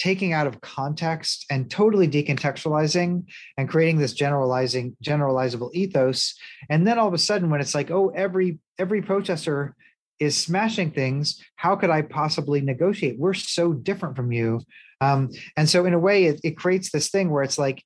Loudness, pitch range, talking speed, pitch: -23 LUFS, 140-185 Hz, 180 wpm, 155 Hz